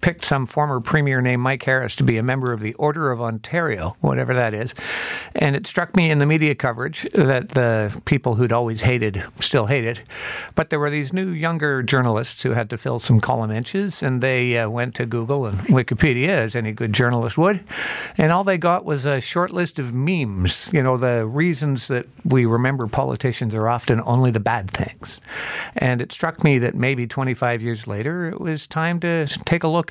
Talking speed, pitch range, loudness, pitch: 205 wpm, 120-155 Hz, -20 LUFS, 130 Hz